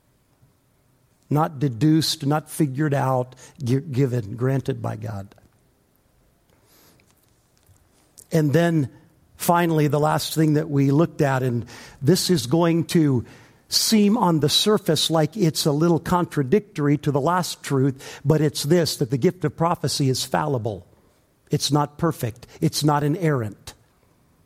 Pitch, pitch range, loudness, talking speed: 145 Hz, 130-160 Hz, -21 LUFS, 130 wpm